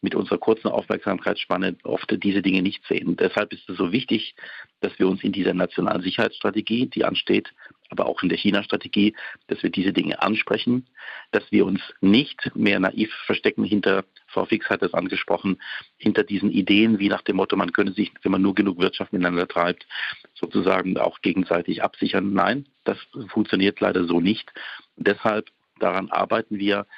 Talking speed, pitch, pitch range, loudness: 175 wpm, 100 Hz, 95-110 Hz, -23 LUFS